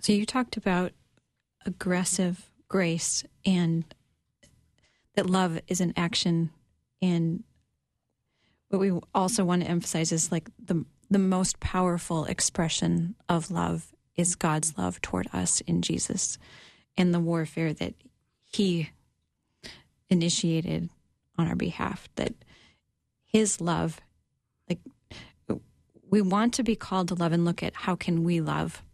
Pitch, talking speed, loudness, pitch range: 175 Hz, 130 wpm, -28 LUFS, 160-190 Hz